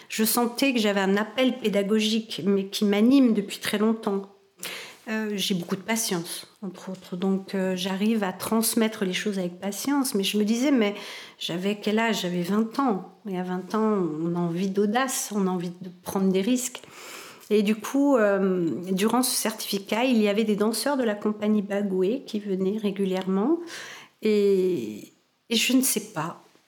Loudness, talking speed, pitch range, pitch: -25 LUFS, 180 wpm, 190-225 Hz, 205 Hz